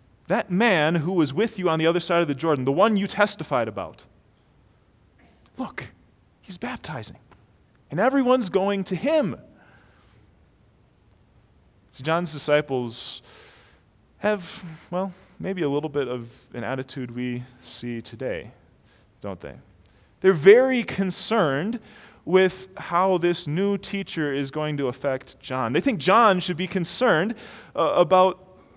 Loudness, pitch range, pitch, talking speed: -23 LUFS, 130-195 Hz, 165 Hz, 135 wpm